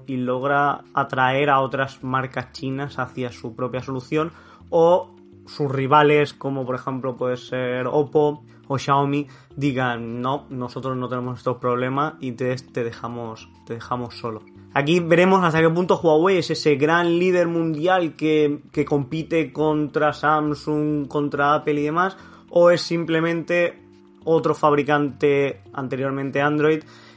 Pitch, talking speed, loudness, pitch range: 140 Hz, 135 wpm, -21 LUFS, 125-155 Hz